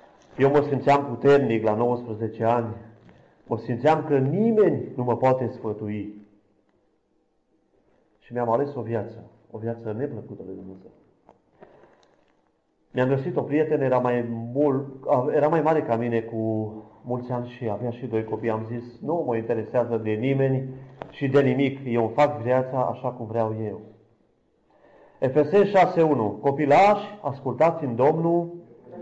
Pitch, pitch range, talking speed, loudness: 125 Hz, 115-140 Hz, 140 wpm, -24 LUFS